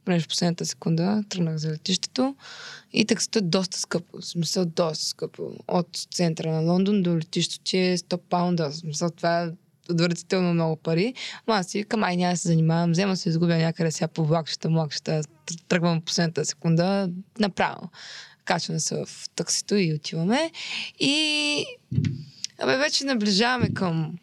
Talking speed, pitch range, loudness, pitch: 165 wpm, 165-200 Hz, -25 LUFS, 175 Hz